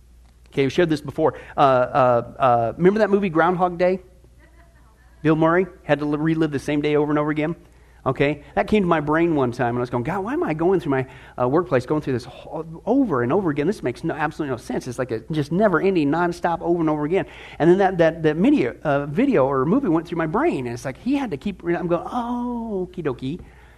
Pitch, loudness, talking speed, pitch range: 155 Hz, -21 LUFS, 240 wpm, 130-180 Hz